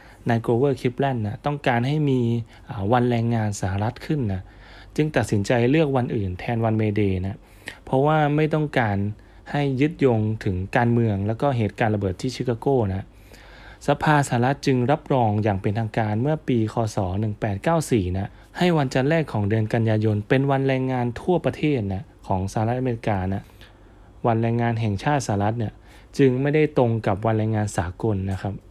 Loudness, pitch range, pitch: -23 LUFS, 105-135 Hz, 115 Hz